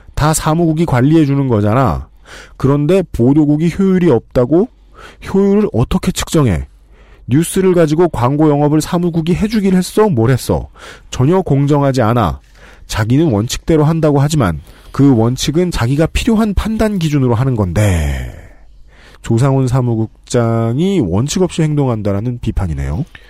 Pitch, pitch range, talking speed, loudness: 140 Hz, 115-170 Hz, 315 characters per minute, -13 LUFS